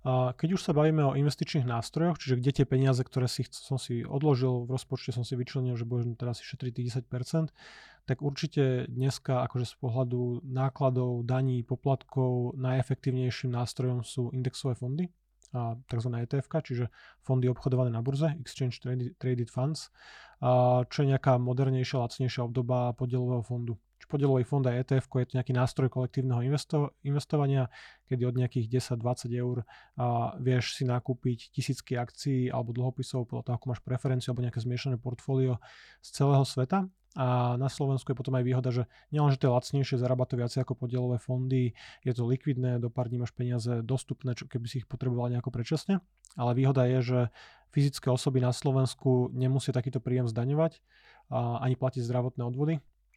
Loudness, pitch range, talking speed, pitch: -30 LUFS, 125-135 Hz, 165 wpm, 130 Hz